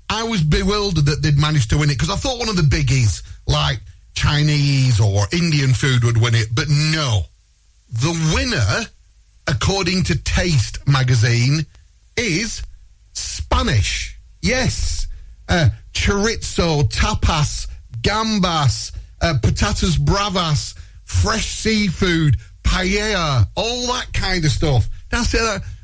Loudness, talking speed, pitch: -18 LUFS, 120 wpm, 125 Hz